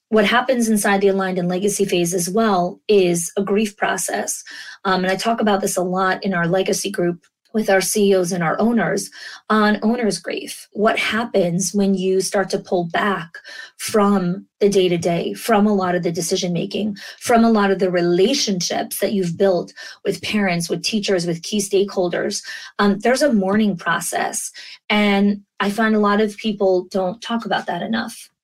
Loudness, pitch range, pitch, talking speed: -19 LUFS, 185-210 Hz, 195 Hz, 185 wpm